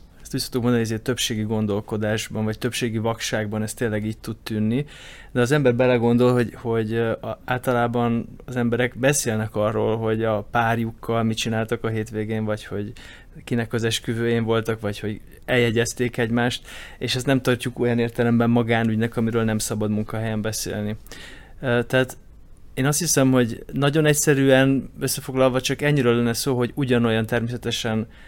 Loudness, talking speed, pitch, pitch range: -22 LUFS, 145 wpm, 115 Hz, 110-125 Hz